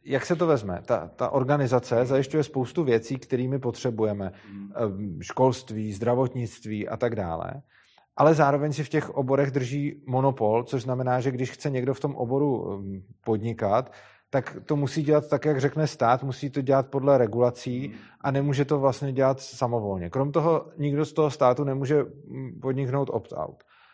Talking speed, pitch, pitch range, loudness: 160 wpm, 135 Hz, 120-145 Hz, -26 LUFS